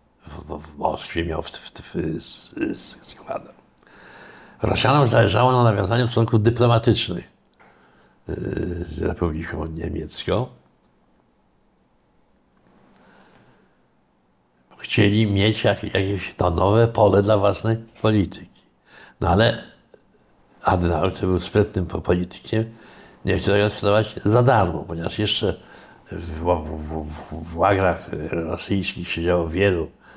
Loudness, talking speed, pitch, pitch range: -21 LUFS, 95 wpm, 95 Hz, 85-110 Hz